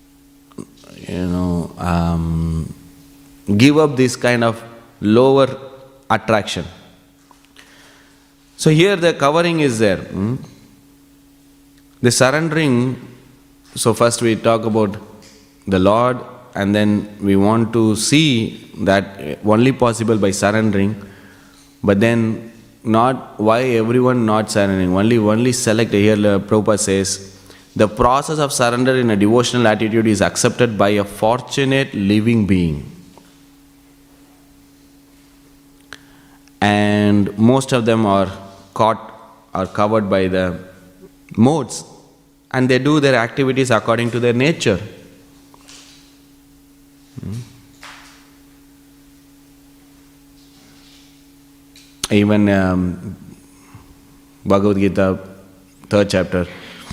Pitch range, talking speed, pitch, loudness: 100-140 Hz, 95 wpm, 120 Hz, -16 LUFS